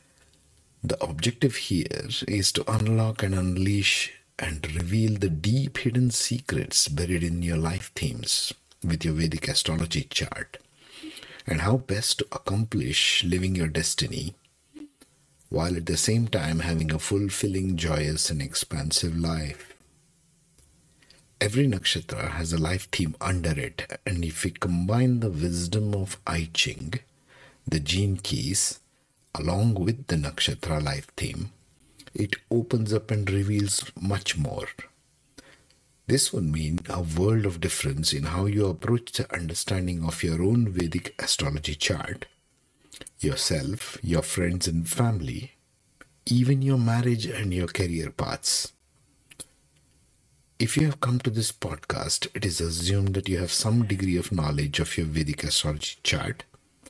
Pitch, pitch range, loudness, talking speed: 100 Hz, 85-125 Hz, -26 LUFS, 135 wpm